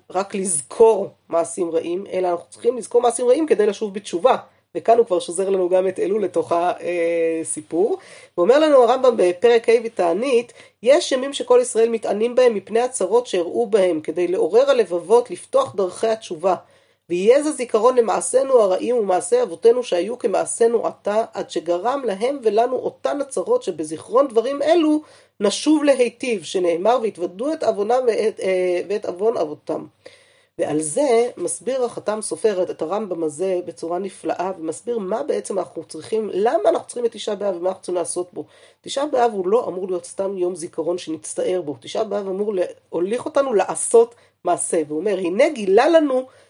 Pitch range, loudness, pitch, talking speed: 180-275 Hz, -20 LUFS, 225 Hz, 160 wpm